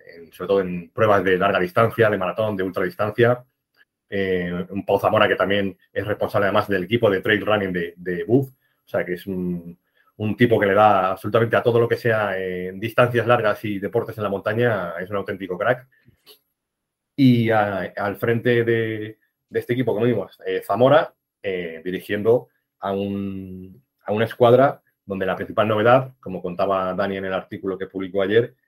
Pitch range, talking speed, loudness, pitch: 95-115 Hz, 185 wpm, -21 LUFS, 100 Hz